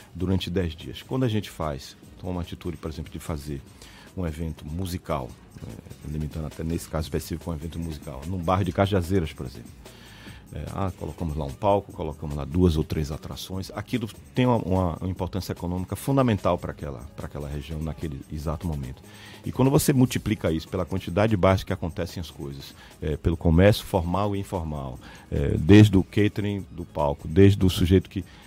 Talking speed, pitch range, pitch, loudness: 185 wpm, 80-100 Hz, 90 Hz, -26 LUFS